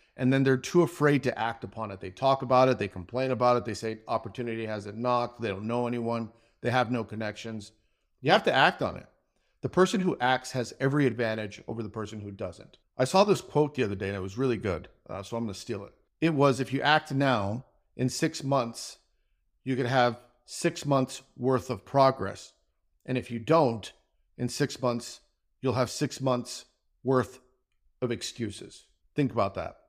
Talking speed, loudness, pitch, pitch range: 205 wpm, -28 LUFS, 125 Hz, 110-135 Hz